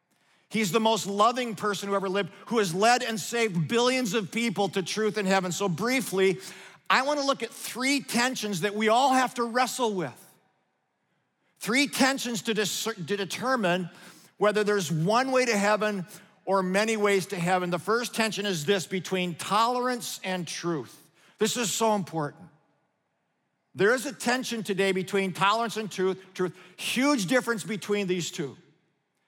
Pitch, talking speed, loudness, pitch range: 210 Hz, 165 wpm, -27 LUFS, 185-235 Hz